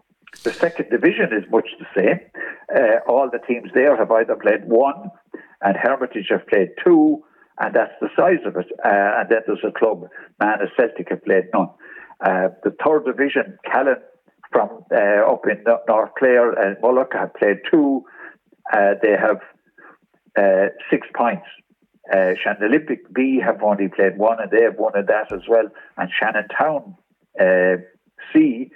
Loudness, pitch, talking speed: -19 LUFS, 180 Hz, 170 wpm